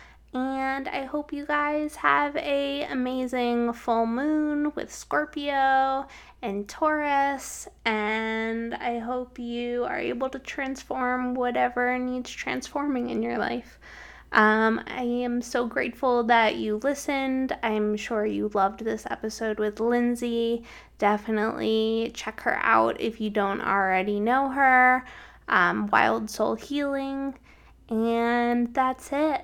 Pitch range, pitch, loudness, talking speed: 225-270 Hz, 245 Hz, -26 LUFS, 125 wpm